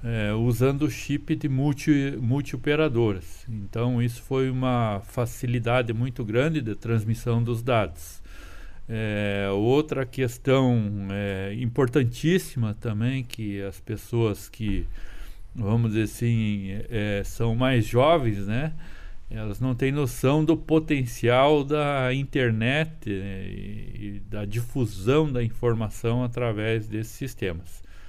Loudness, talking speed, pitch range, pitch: -25 LUFS, 115 wpm, 105-130 Hz, 115 Hz